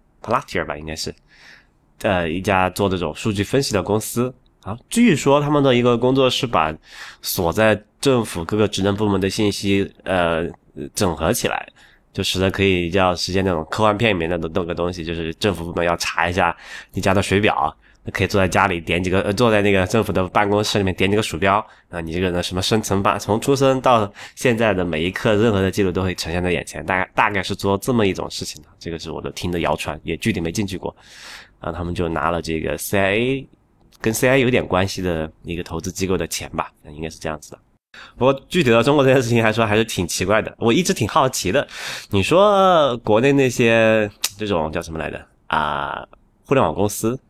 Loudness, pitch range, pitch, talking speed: -19 LUFS, 90-110 Hz, 100 Hz, 325 characters per minute